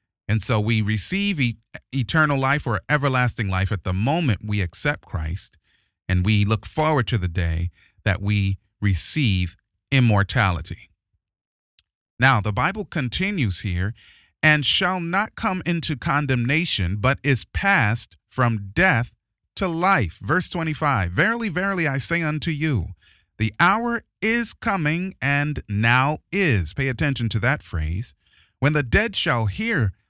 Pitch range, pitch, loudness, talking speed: 100-150 Hz, 120 Hz, -22 LUFS, 140 wpm